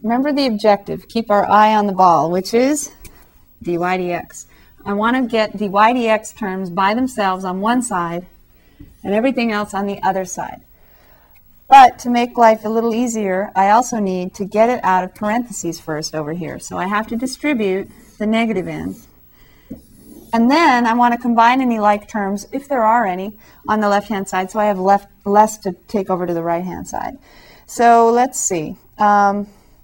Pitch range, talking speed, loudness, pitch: 190-230 Hz, 190 wpm, -16 LUFS, 210 Hz